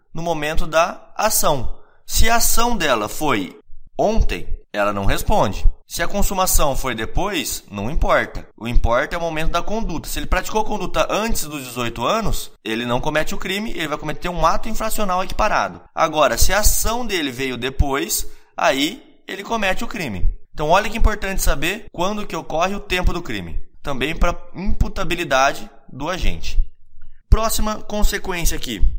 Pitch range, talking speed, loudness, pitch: 125-205 Hz, 165 wpm, -21 LUFS, 170 Hz